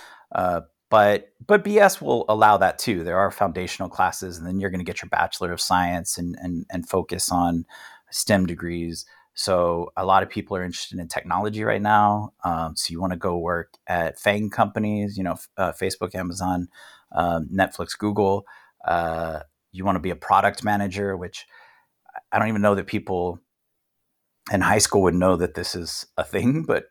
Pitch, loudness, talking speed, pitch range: 95 Hz, -23 LUFS, 185 wpm, 85-105 Hz